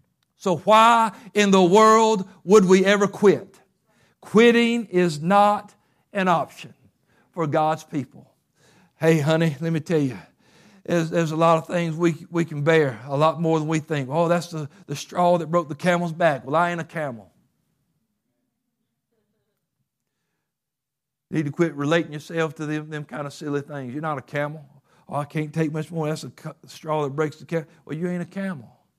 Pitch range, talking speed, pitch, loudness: 150-175 Hz, 185 wpm, 160 Hz, -21 LUFS